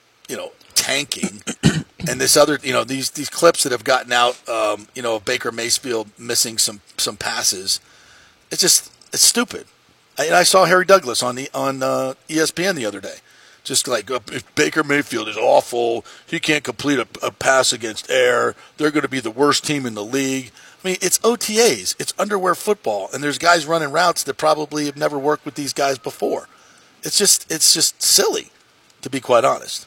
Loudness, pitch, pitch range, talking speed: -18 LUFS, 145 Hz, 130-170 Hz, 195 wpm